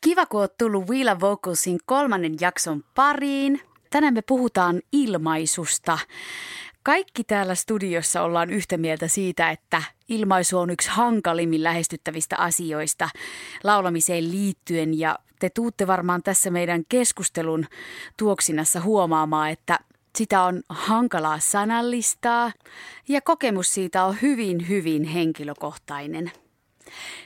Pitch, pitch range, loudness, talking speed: 185 Hz, 165-235 Hz, -23 LUFS, 105 wpm